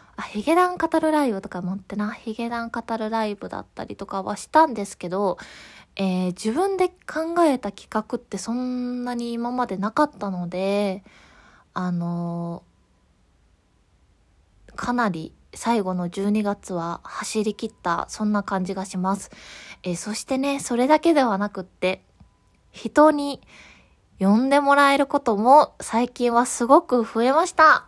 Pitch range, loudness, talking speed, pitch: 185-250 Hz, -23 LUFS, 275 characters per minute, 215 Hz